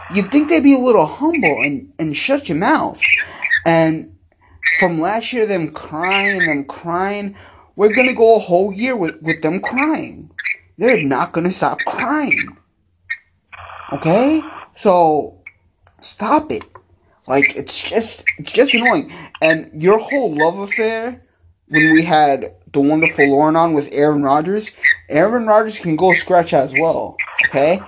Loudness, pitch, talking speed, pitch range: -15 LUFS, 175 Hz, 155 wpm, 155-225 Hz